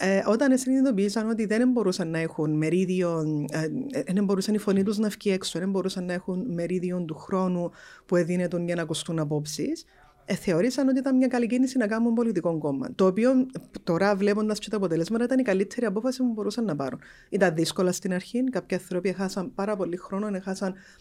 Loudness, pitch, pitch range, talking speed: -26 LUFS, 195 Hz, 180-230 Hz, 190 wpm